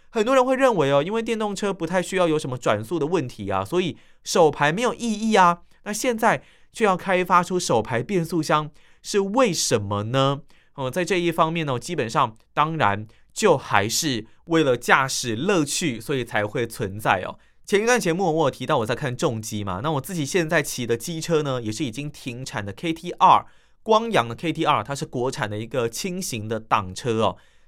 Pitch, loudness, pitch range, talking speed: 155 Hz, -22 LUFS, 125-180 Hz, 295 characters per minute